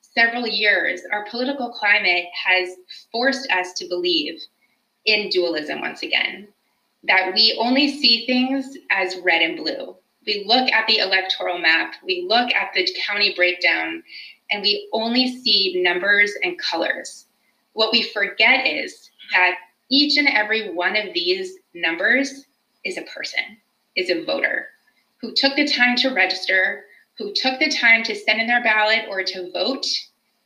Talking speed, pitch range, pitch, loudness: 155 wpm, 190-255 Hz, 220 Hz, -19 LUFS